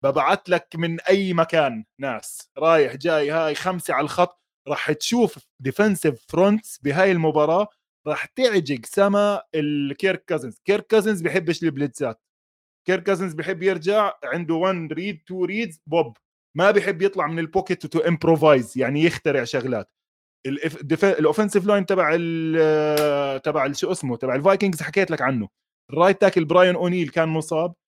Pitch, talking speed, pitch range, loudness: 170 Hz, 140 wpm, 155-195 Hz, -21 LUFS